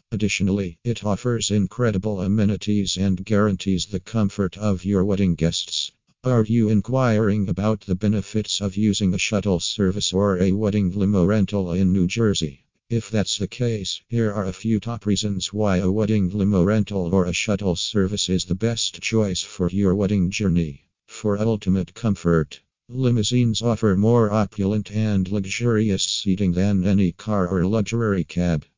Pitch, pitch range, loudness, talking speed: 100 Hz, 95-110 Hz, -22 LUFS, 155 wpm